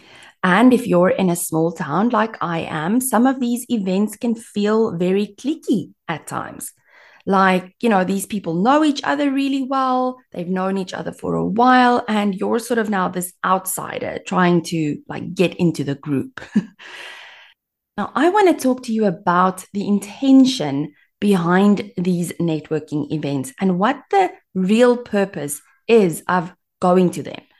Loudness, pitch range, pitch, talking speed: -19 LUFS, 180-245 Hz, 200 Hz, 165 wpm